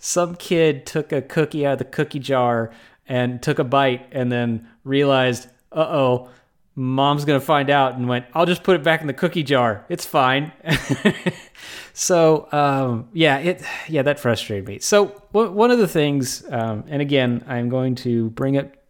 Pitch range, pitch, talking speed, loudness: 125-160 Hz, 140 Hz, 185 wpm, -20 LUFS